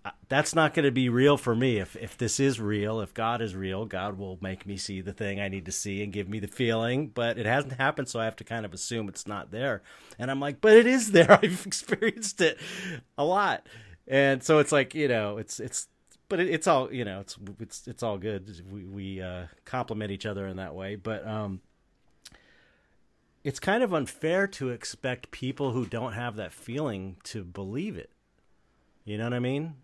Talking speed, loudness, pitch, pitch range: 220 wpm, -28 LUFS, 115 Hz, 100-140 Hz